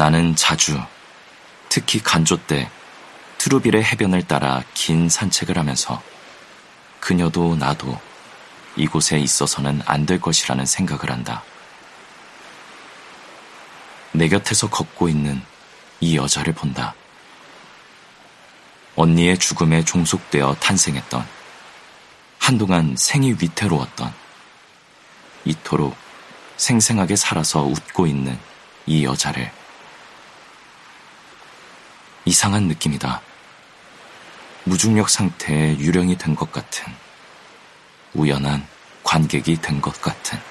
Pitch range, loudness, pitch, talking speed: 70-90 Hz, -19 LUFS, 80 Hz, 200 characters per minute